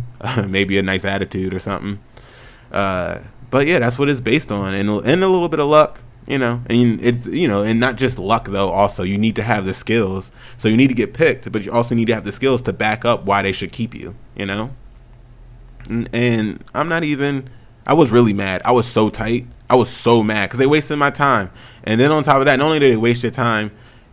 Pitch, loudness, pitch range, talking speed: 120 Hz, -17 LUFS, 105-130 Hz, 245 wpm